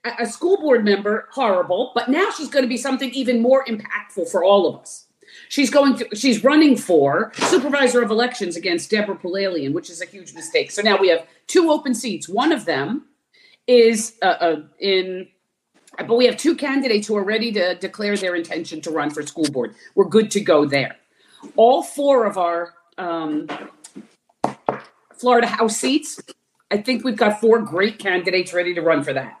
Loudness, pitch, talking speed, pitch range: -19 LUFS, 220 Hz, 185 wpm, 180-255 Hz